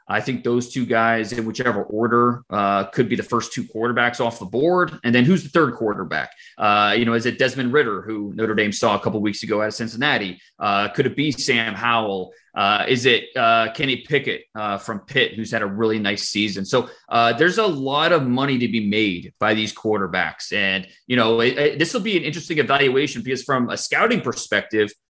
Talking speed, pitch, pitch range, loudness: 215 wpm, 115 Hz, 105-130 Hz, -20 LUFS